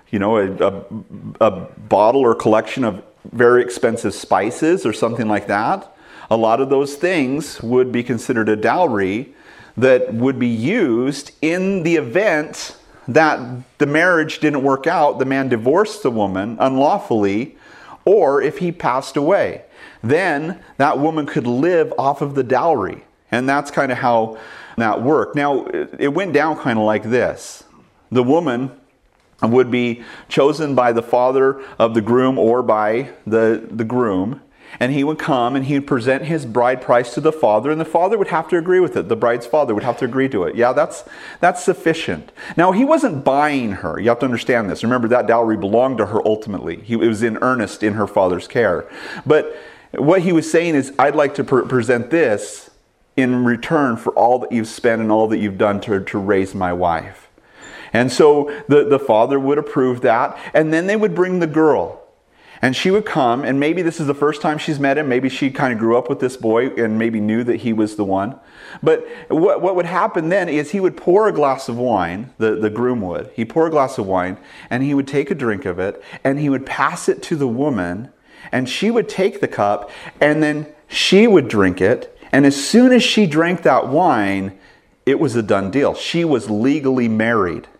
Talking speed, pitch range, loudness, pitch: 205 wpm, 115-155 Hz, -17 LUFS, 135 Hz